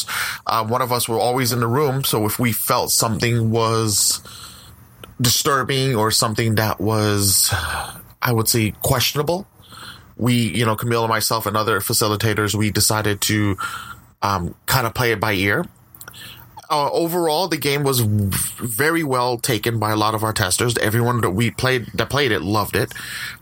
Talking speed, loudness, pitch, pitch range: 170 wpm, -19 LUFS, 115 Hz, 110-125 Hz